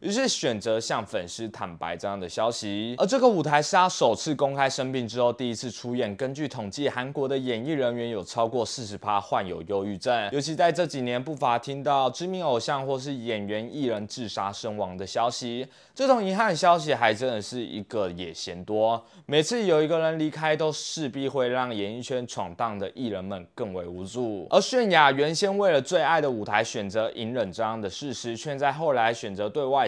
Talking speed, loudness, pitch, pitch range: 305 characters per minute, -26 LUFS, 125 Hz, 110-150 Hz